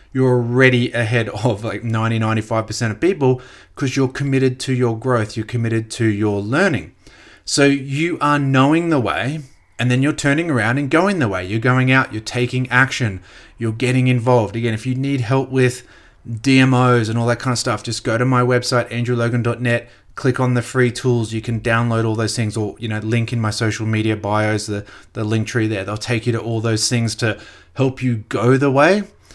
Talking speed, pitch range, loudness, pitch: 205 wpm, 110-130 Hz, -18 LUFS, 120 Hz